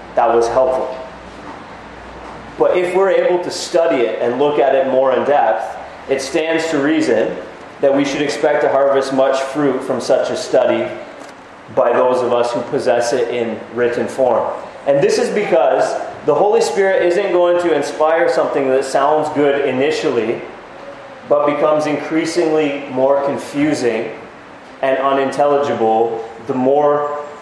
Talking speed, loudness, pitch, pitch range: 150 wpm, -16 LUFS, 145 Hz, 130-155 Hz